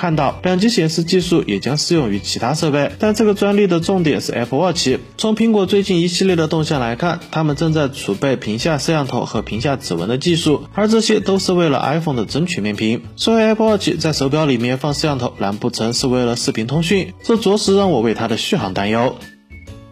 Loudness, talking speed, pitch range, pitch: -17 LUFS, 390 characters per minute, 120-185 Hz, 155 Hz